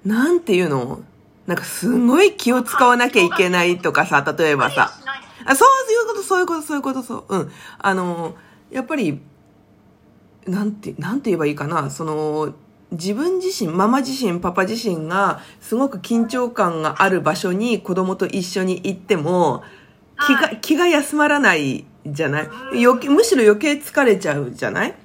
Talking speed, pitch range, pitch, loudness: 325 characters per minute, 175-270 Hz, 210 Hz, -18 LUFS